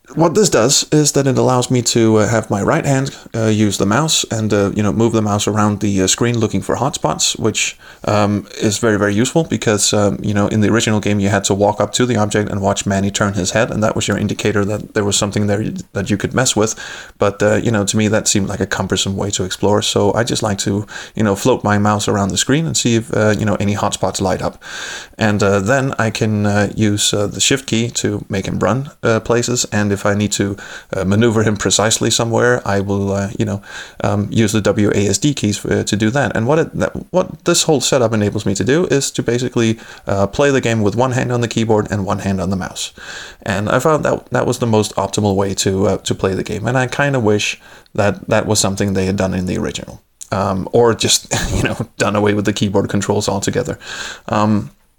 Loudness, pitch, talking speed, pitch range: -16 LUFS, 105 Hz, 250 wpm, 100-115 Hz